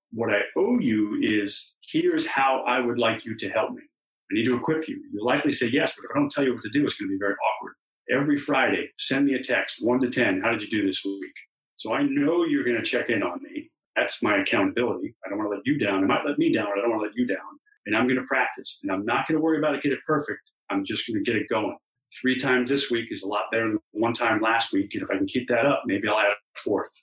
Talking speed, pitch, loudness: 300 wpm, 130 Hz, -25 LUFS